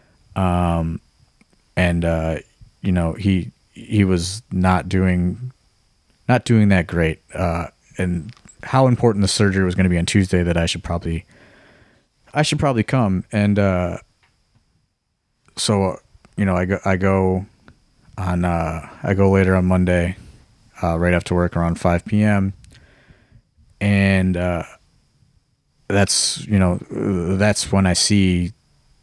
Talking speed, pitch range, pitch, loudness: 140 wpm, 90-100 Hz, 95 Hz, -19 LUFS